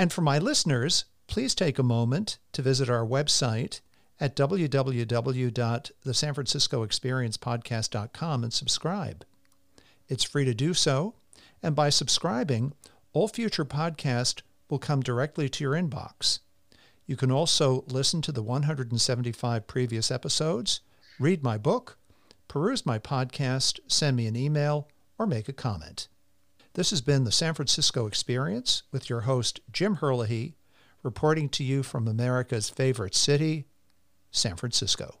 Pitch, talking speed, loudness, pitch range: 135 Hz, 130 wpm, -27 LUFS, 120-150 Hz